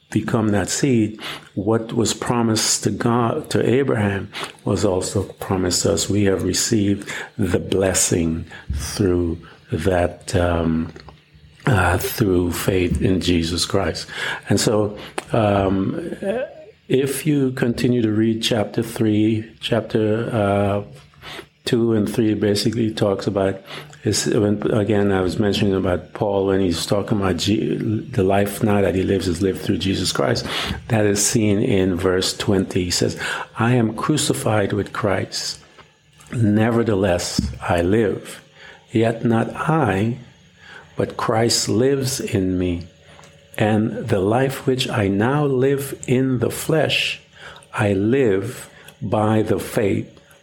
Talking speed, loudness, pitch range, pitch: 130 wpm, -20 LUFS, 95-115 Hz, 105 Hz